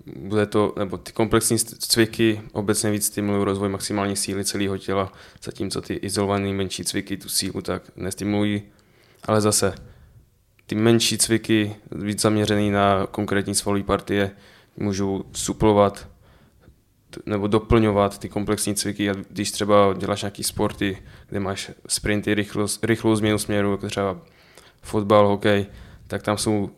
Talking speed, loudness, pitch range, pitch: 135 wpm, -22 LUFS, 100-105 Hz, 105 Hz